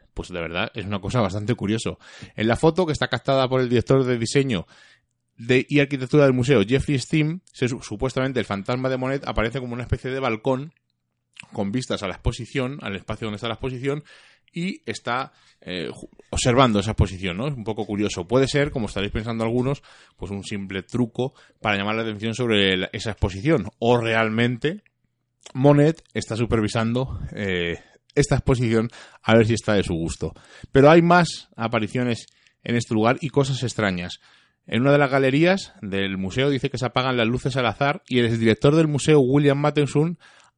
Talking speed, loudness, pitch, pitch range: 185 wpm, -22 LUFS, 120 Hz, 110-135 Hz